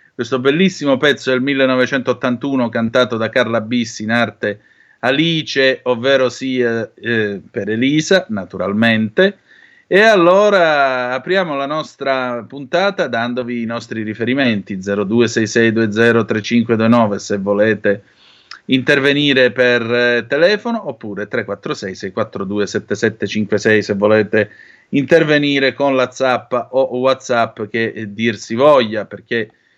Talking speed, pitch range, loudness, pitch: 105 wpm, 110-135 Hz, -15 LUFS, 120 Hz